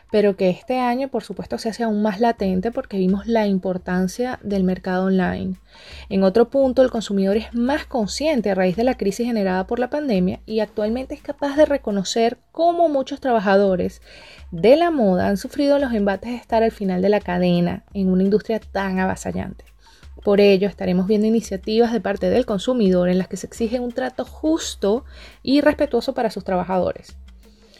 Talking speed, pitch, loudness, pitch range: 185 wpm, 215 Hz, -20 LUFS, 190-245 Hz